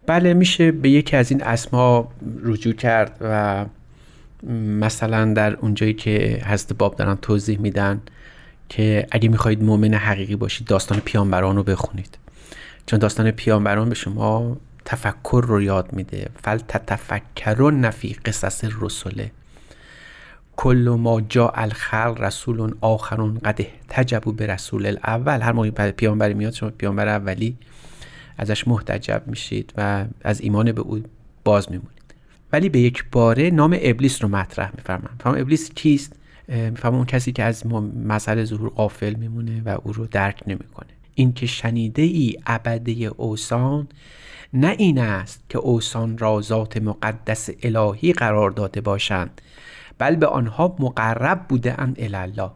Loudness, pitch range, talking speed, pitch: -21 LUFS, 105-125 Hz, 140 wpm, 110 Hz